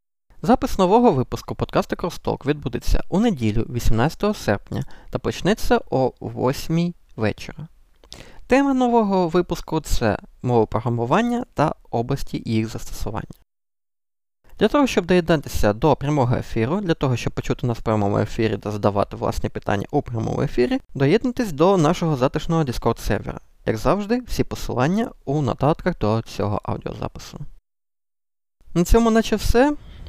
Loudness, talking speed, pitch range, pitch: -22 LUFS, 130 wpm, 110-180 Hz, 130 Hz